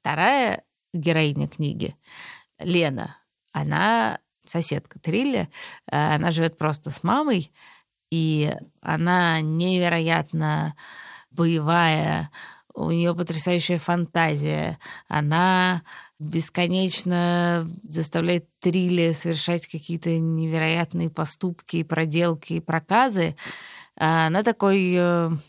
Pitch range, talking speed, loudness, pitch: 160-175 Hz, 80 wpm, -23 LUFS, 165 Hz